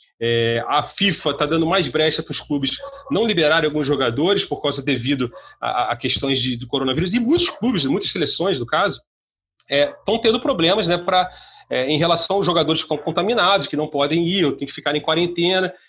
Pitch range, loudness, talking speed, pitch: 145-190 Hz, -19 LUFS, 200 wpm, 160 Hz